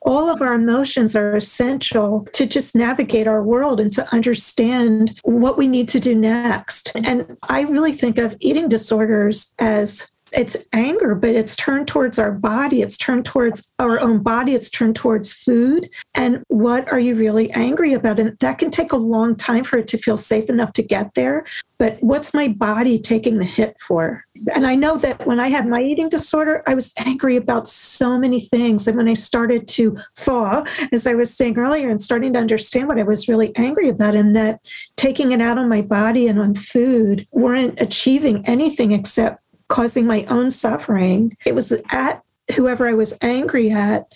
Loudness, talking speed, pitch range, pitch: -17 LUFS, 195 wpm, 220-260 Hz, 240 Hz